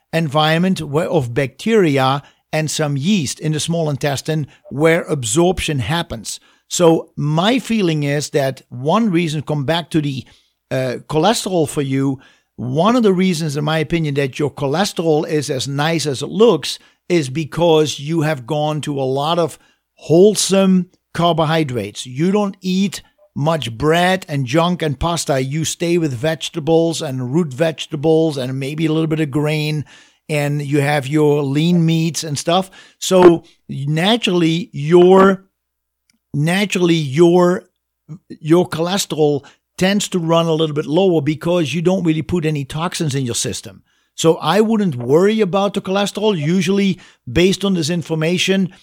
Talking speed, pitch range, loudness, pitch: 150 wpm, 150-180 Hz, -17 LUFS, 160 Hz